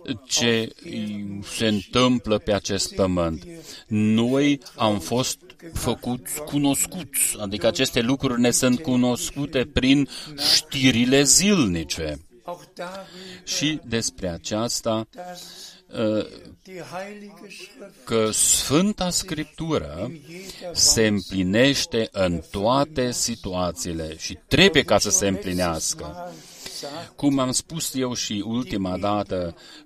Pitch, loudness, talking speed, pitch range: 125 Hz, -22 LUFS, 90 wpm, 105-150 Hz